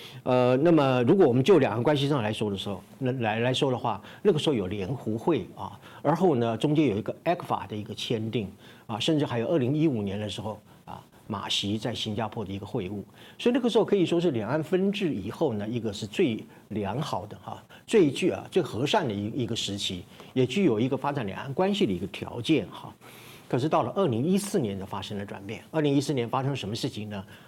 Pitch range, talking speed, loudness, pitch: 105-150 Hz, 350 characters per minute, -27 LUFS, 120 Hz